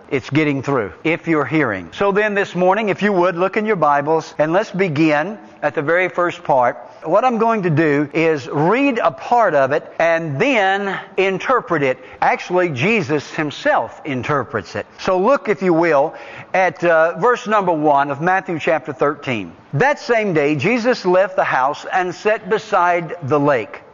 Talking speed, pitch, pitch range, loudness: 180 wpm, 175 Hz, 150-200 Hz, -17 LUFS